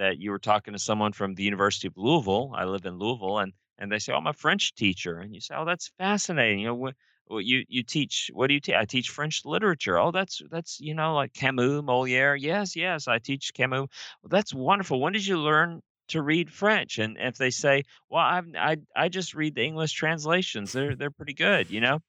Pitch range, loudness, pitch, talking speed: 110-165 Hz, -26 LUFS, 140 Hz, 235 wpm